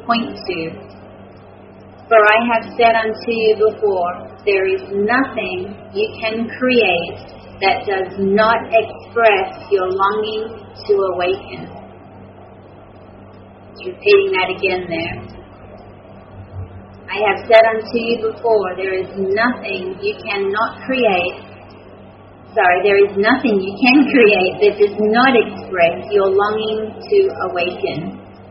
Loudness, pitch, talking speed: -16 LUFS, 200 Hz, 115 wpm